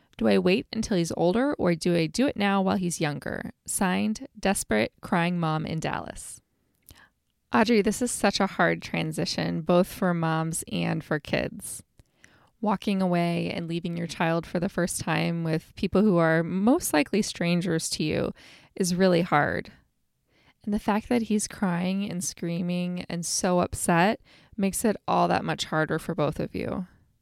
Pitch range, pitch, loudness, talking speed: 165-200 Hz, 180 Hz, -26 LUFS, 170 wpm